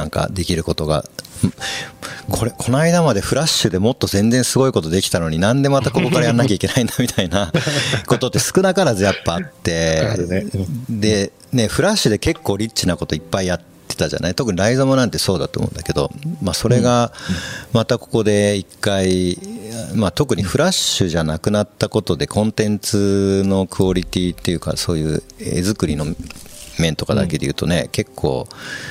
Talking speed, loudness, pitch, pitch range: 390 characters per minute, -18 LUFS, 105 Hz, 90-125 Hz